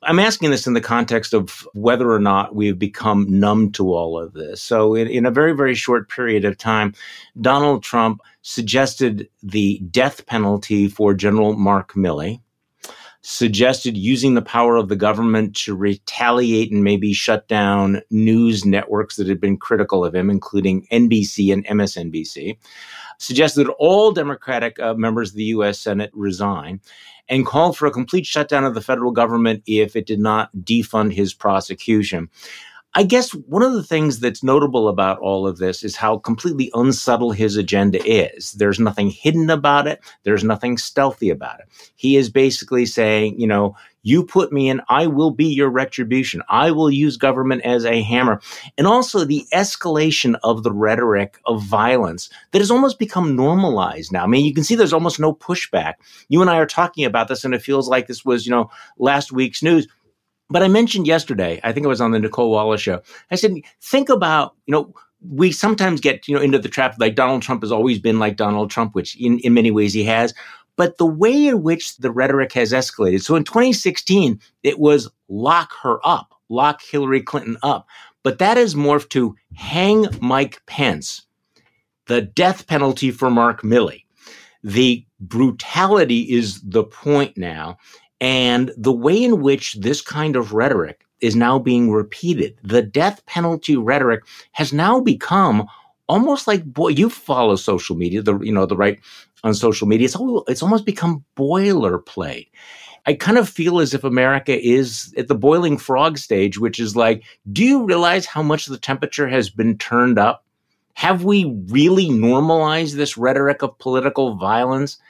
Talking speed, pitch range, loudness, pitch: 180 wpm, 110-150 Hz, -17 LUFS, 125 Hz